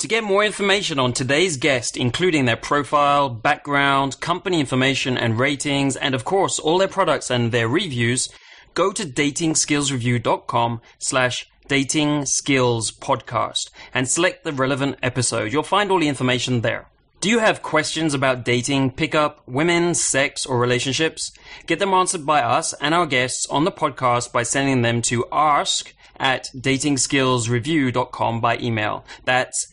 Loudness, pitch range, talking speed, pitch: -20 LUFS, 125-155 Hz, 150 wpm, 135 Hz